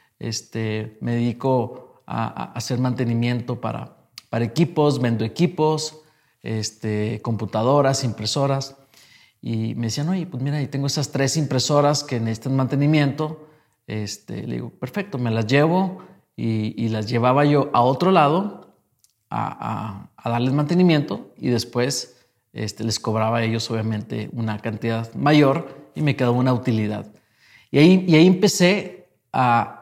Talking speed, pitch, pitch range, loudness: 145 wpm, 125 Hz, 115-145 Hz, -21 LUFS